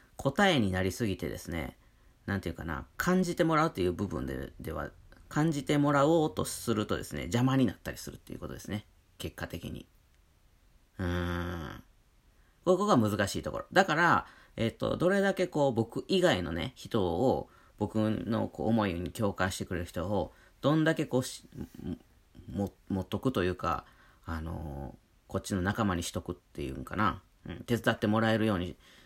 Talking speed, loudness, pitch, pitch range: 335 characters per minute, -31 LUFS, 100 Hz, 85-125 Hz